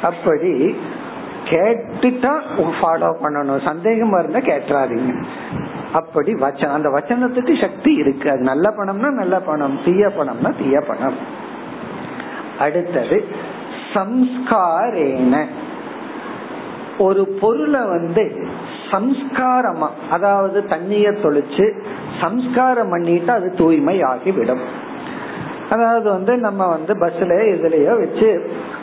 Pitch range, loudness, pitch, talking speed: 175-255 Hz, -18 LUFS, 210 Hz, 85 wpm